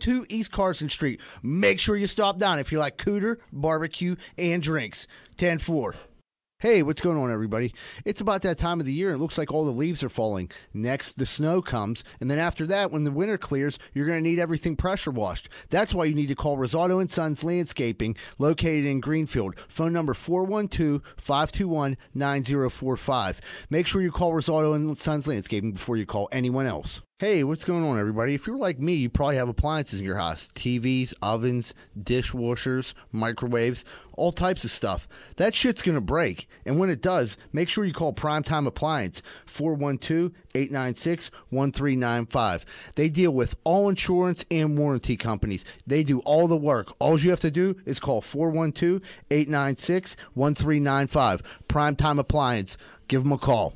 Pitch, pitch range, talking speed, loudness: 150 Hz, 130-170 Hz, 175 wpm, -26 LUFS